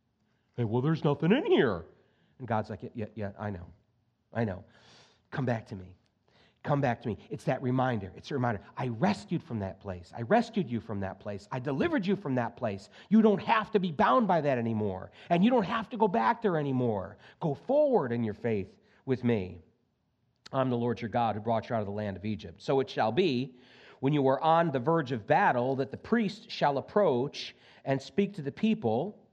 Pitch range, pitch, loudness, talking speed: 110-160 Hz, 125 Hz, -30 LUFS, 220 wpm